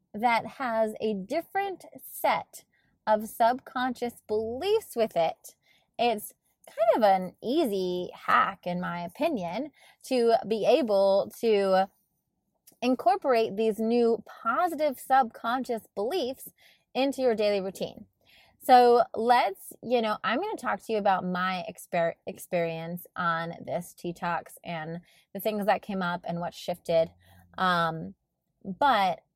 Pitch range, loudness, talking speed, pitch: 180-245 Hz, -27 LUFS, 125 wpm, 215 Hz